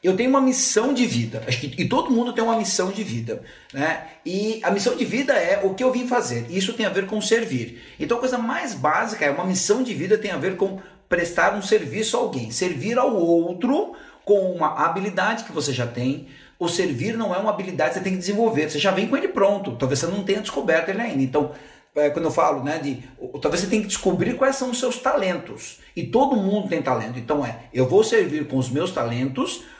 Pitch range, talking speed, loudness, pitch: 150-225 Hz, 230 wpm, -22 LUFS, 190 Hz